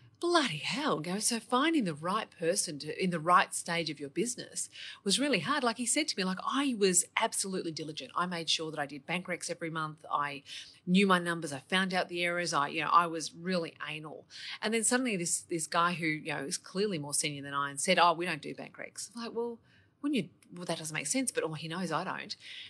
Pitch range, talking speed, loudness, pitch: 155-205 Hz, 245 wpm, -31 LUFS, 175 Hz